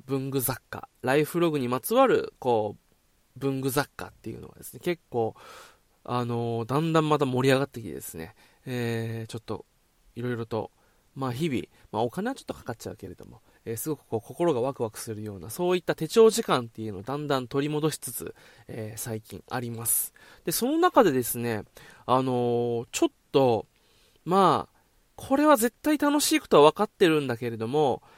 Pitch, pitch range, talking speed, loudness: 130 Hz, 115-160 Hz, 370 characters per minute, -26 LUFS